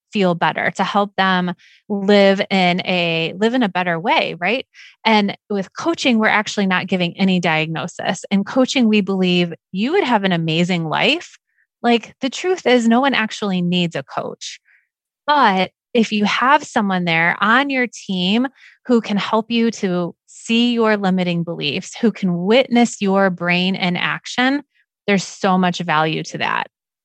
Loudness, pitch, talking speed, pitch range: -17 LUFS, 200 Hz, 165 wpm, 180-230 Hz